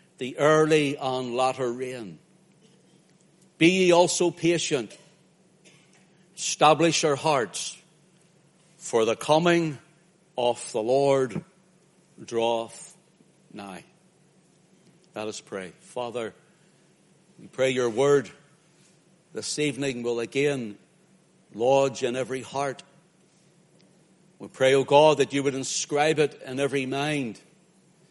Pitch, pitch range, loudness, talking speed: 160 Hz, 135-180 Hz, -24 LUFS, 105 wpm